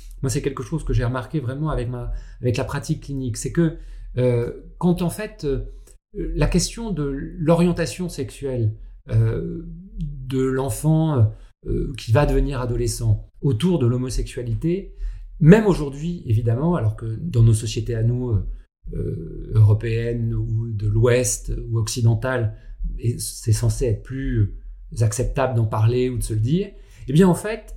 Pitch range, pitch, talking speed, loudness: 115-155 Hz, 125 Hz, 155 wpm, -22 LUFS